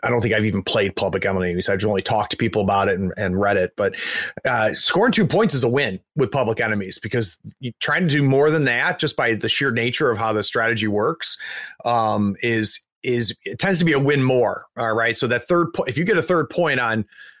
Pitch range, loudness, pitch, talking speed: 105-135 Hz, -20 LUFS, 115 Hz, 245 wpm